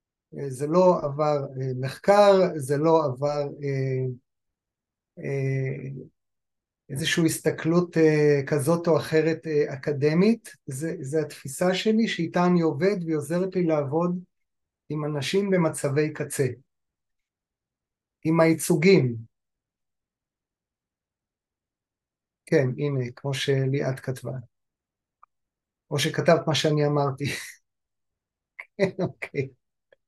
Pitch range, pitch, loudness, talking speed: 135-165 Hz, 150 Hz, -24 LUFS, 90 wpm